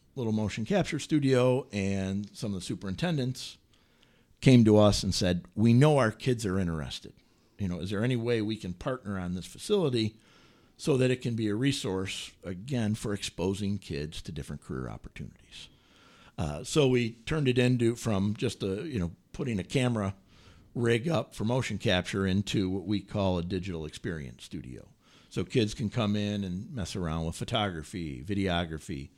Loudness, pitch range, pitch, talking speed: -30 LUFS, 95-120 Hz, 105 Hz, 175 wpm